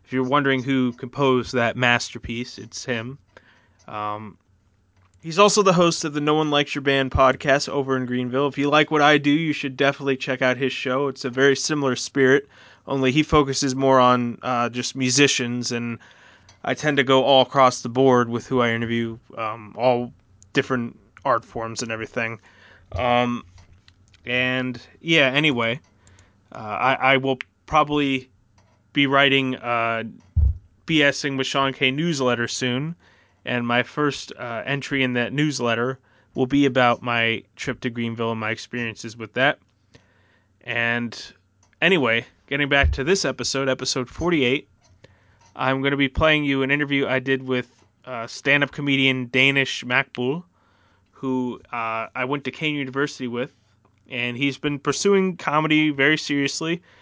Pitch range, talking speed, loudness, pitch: 115-140 Hz, 155 wpm, -21 LUFS, 130 Hz